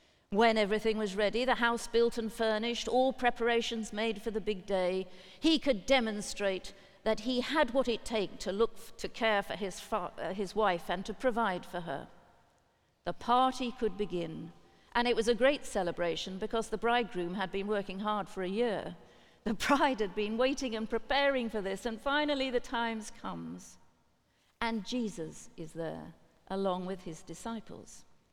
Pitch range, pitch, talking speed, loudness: 195-235 Hz, 220 Hz, 175 wpm, -33 LUFS